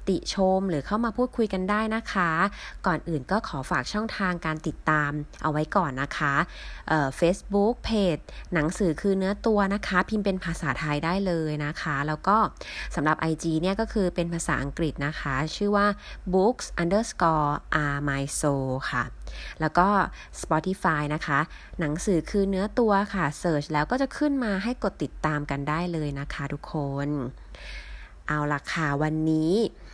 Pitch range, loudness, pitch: 150-195 Hz, -26 LUFS, 170 Hz